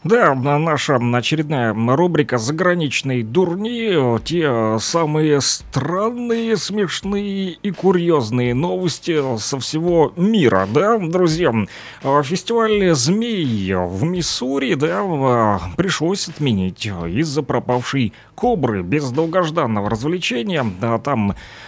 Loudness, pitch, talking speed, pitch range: -18 LUFS, 150 Hz, 90 wpm, 120-180 Hz